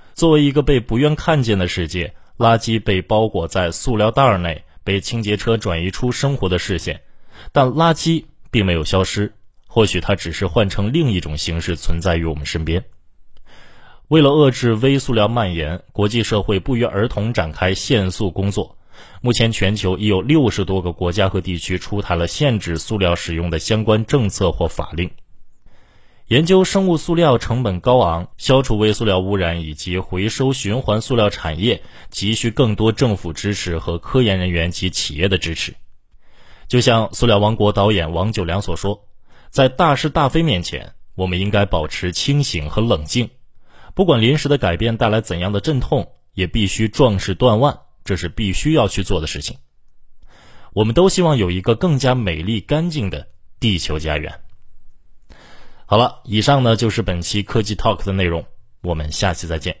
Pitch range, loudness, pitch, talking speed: 90-120 Hz, -18 LUFS, 105 Hz, 270 characters per minute